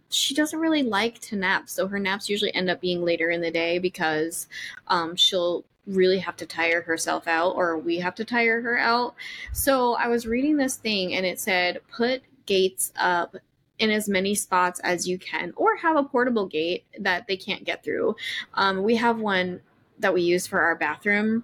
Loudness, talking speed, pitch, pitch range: -24 LUFS, 200 wpm, 190 Hz, 175-235 Hz